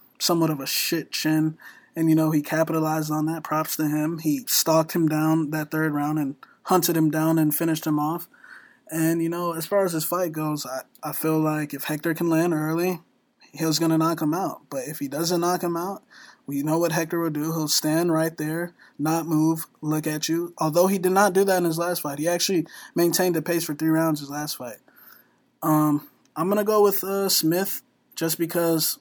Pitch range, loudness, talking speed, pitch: 155-170 Hz, -24 LUFS, 220 wpm, 160 Hz